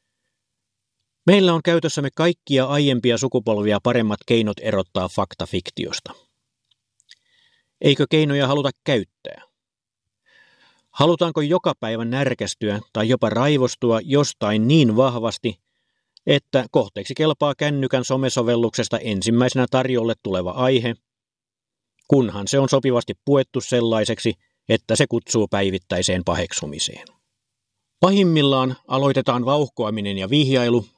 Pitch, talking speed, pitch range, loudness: 125 Hz, 95 wpm, 110-140 Hz, -20 LUFS